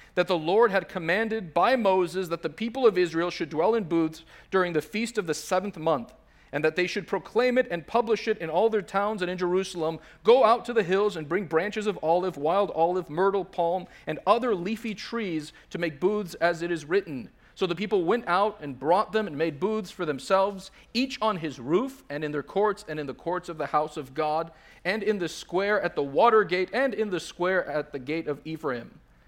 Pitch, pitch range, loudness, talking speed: 185 Hz, 160-210 Hz, -27 LUFS, 225 wpm